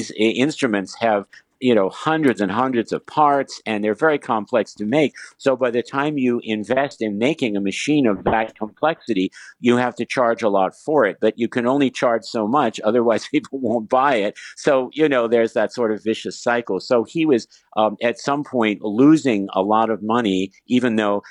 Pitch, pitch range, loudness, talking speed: 120 Hz, 110-135 Hz, -20 LUFS, 205 wpm